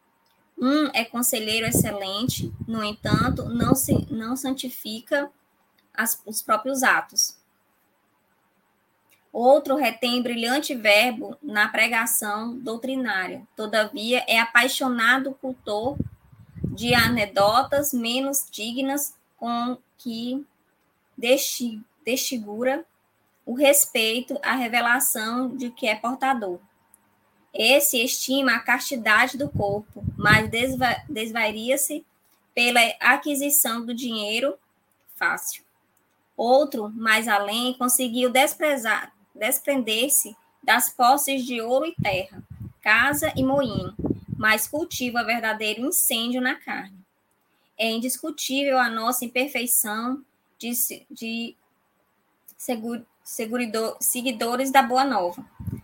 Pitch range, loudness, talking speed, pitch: 225-270 Hz, -22 LUFS, 95 wpm, 250 Hz